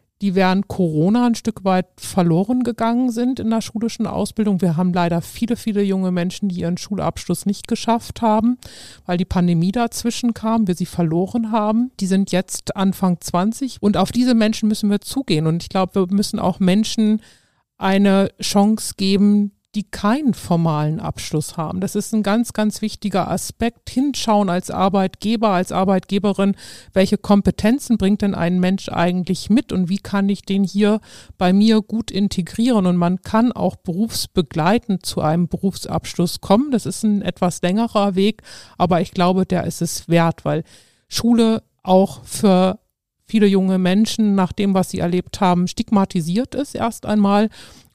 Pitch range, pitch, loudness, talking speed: 180-220 Hz, 195 Hz, -19 LUFS, 165 wpm